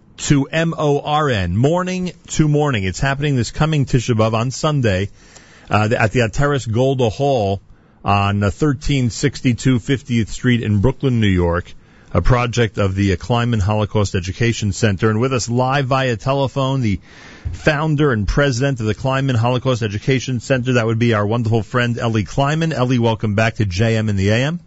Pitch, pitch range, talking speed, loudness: 120 Hz, 105-135 Hz, 165 wpm, -18 LUFS